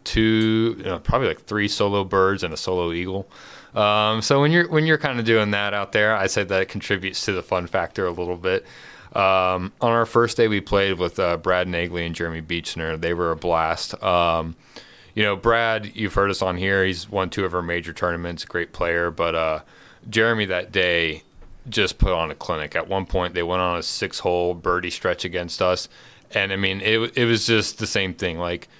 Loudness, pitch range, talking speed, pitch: -22 LUFS, 85-105 Hz, 220 wpm, 95 Hz